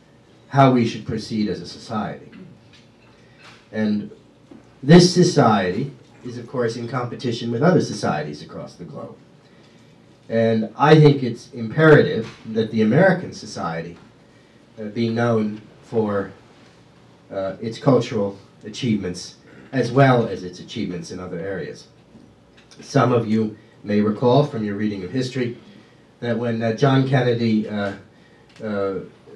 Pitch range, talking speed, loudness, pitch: 110-125 Hz, 130 wpm, -20 LUFS, 115 Hz